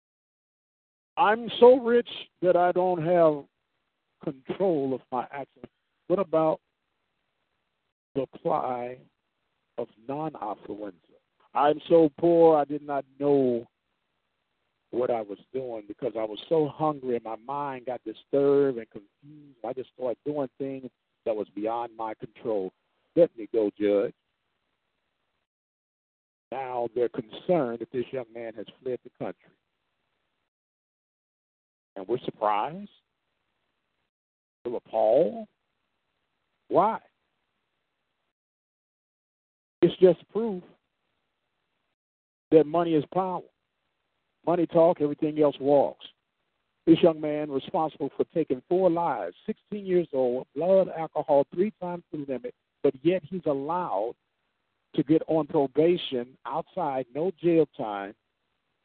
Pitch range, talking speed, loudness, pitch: 125-170 Hz, 115 wpm, -26 LUFS, 145 Hz